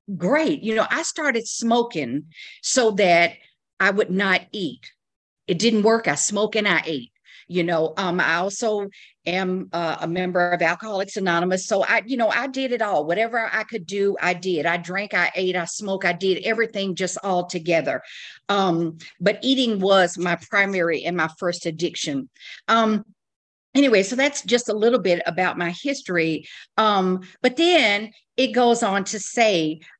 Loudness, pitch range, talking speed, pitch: -21 LUFS, 175-225 Hz, 175 wpm, 195 Hz